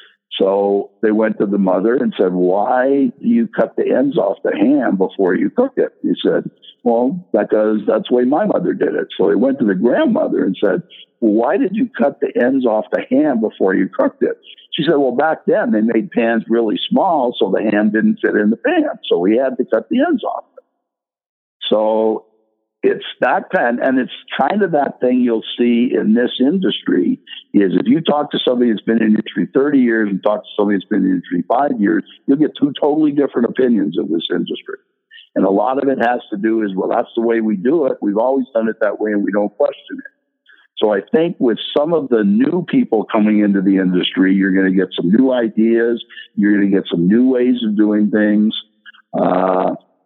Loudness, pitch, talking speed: -16 LUFS, 115 Hz, 225 wpm